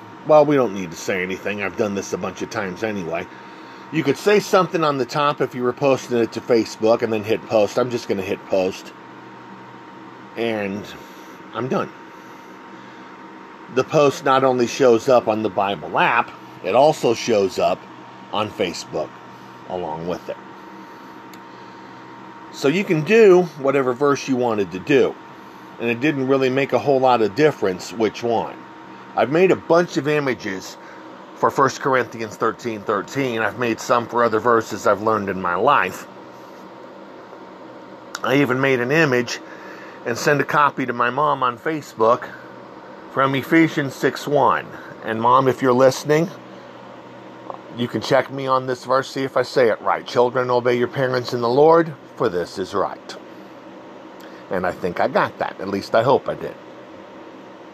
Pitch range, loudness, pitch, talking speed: 95-135 Hz, -19 LUFS, 120 Hz, 170 wpm